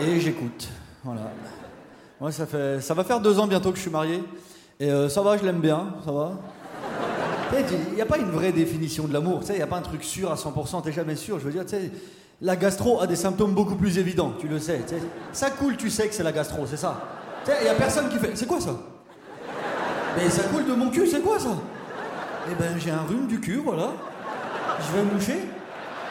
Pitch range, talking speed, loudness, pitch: 155-200 Hz, 255 wpm, -26 LUFS, 180 Hz